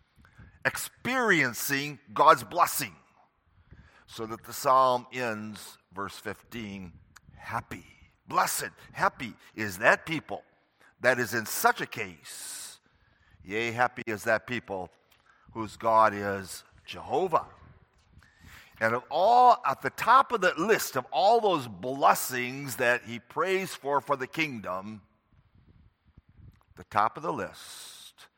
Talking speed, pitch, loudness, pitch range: 120 wpm, 110 Hz, -27 LUFS, 100-125 Hz